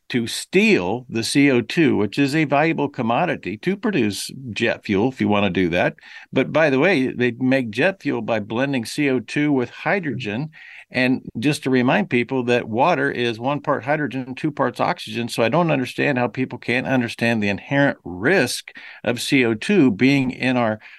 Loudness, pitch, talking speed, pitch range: -20 LUFS, 130 Hz, 175 wpm, 115-140 Hz